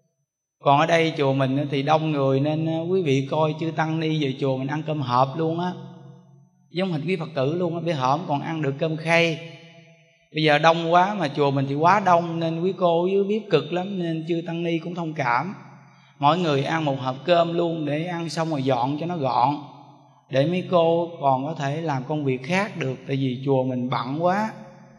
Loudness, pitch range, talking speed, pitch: -23 LUFS, 140-170 Hz, 225 wpm, 160 Hz